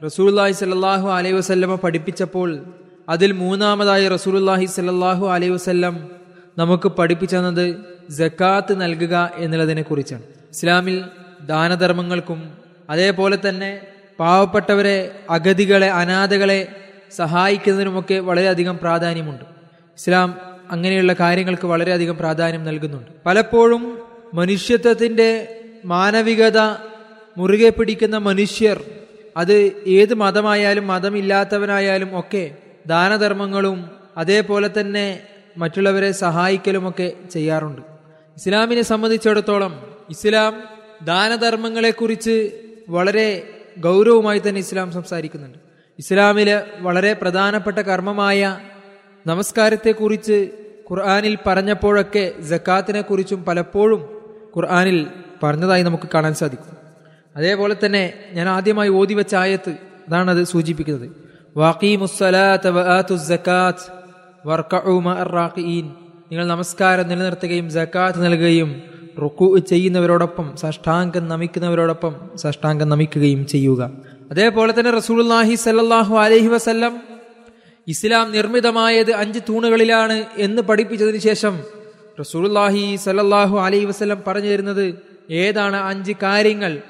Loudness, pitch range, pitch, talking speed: -17 LUFS, 175-205 Hz, 190 Hz, 75 wpm